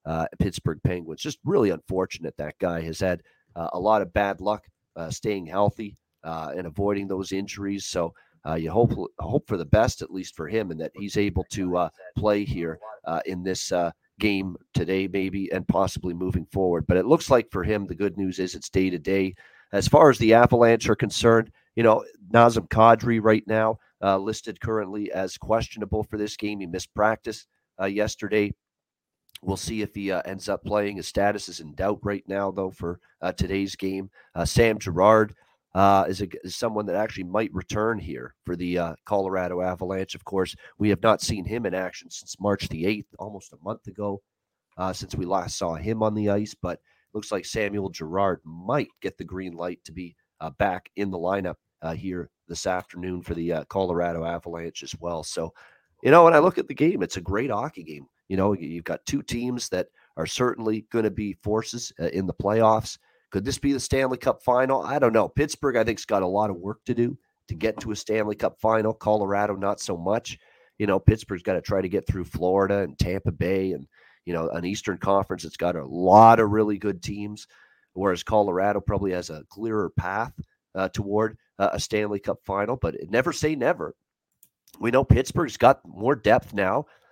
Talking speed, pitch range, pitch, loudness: 210 wpm, 90-110 Hz, 100 Hz, -25 LUFS